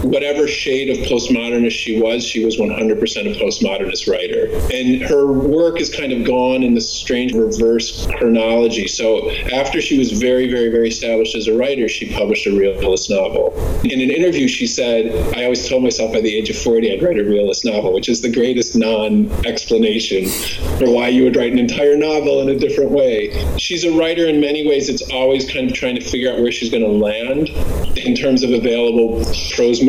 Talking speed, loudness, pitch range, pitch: 200 wpm, -16 LUFS, 115-155 Hz, 125 Hz